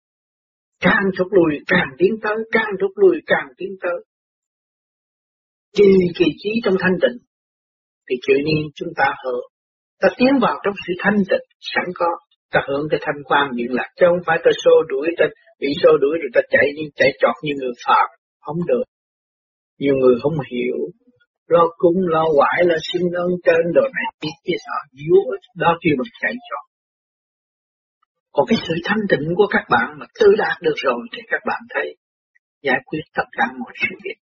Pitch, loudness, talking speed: 200 Hz, -18 LUFS, 190 wpm